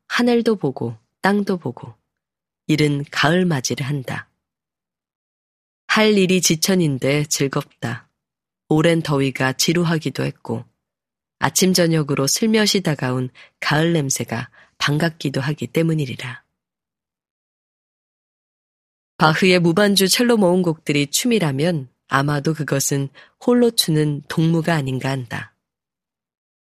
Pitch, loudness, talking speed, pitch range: 150 Hz, -19 LUFS, 230 characters per minute, 135-175 Hz